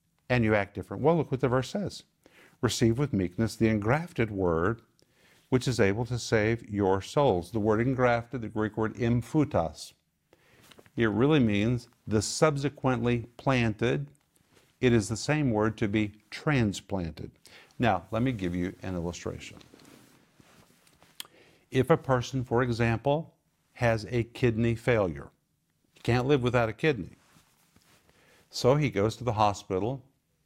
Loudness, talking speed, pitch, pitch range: -28 LUFS, 140 wpm, 120 Hz, 110-130 Hz